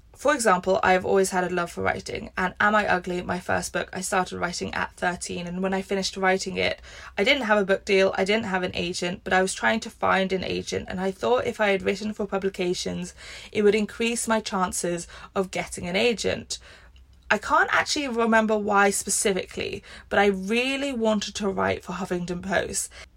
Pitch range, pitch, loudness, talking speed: 180-215 Hz, 190 Hz, -24 LUFS, 205 wpm